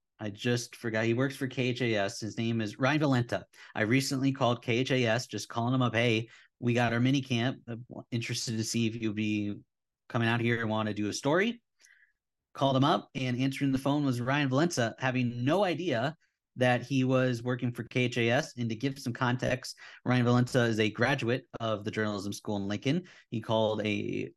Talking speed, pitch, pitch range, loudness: 195 wpm, 120 Hz, 115-130 Hz, -30 LUFS